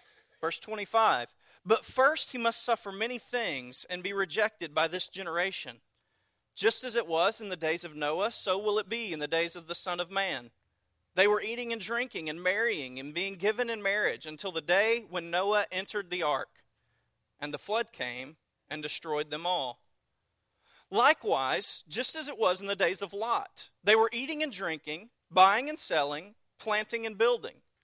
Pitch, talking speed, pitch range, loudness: 195 Hz, 185 wpm, 160-225 Hz, -30 LUFS